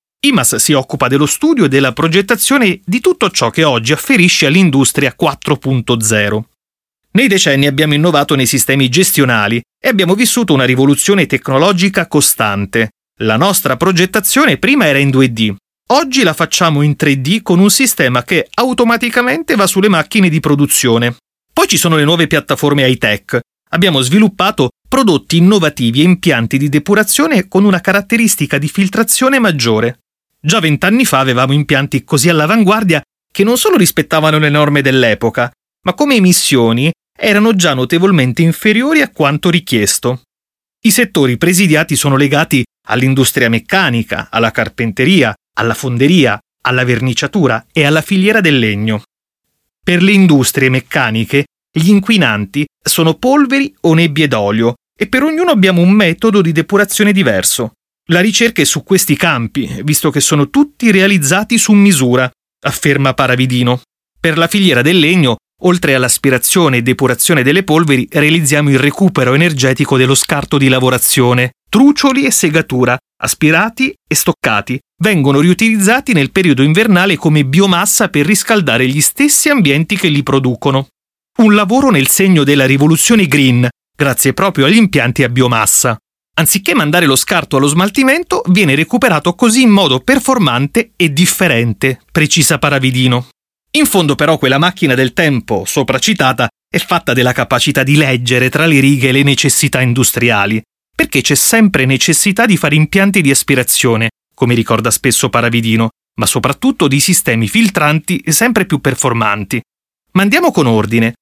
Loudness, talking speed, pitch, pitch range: -10 LUFS, 140 wpm, 150 Hz, 130-195 Hz